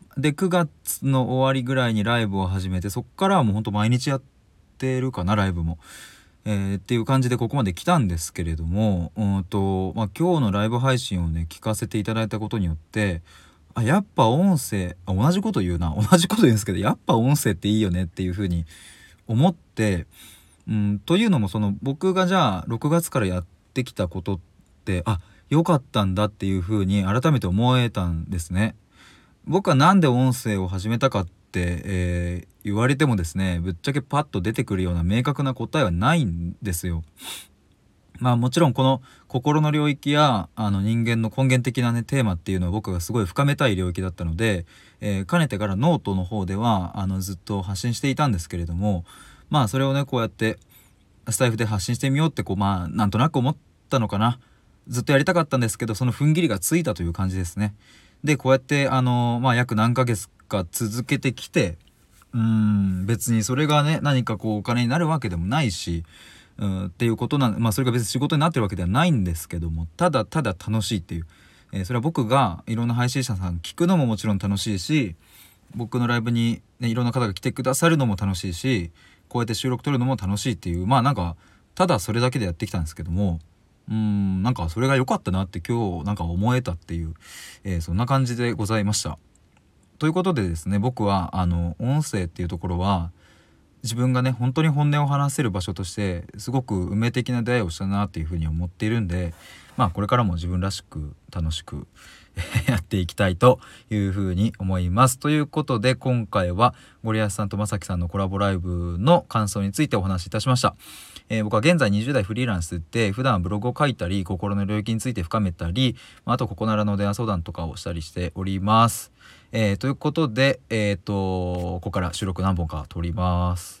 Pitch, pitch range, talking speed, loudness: 105 Hz, 95-130 Hz, 415 characters per minute, -23 LUFS